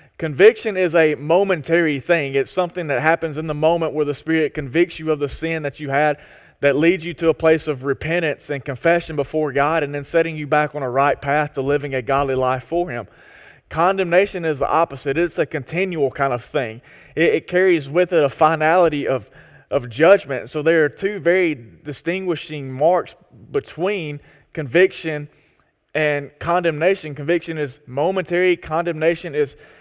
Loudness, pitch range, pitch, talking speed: -19 LUFS, 145-175 Hz, 155 Hz, 175 wpm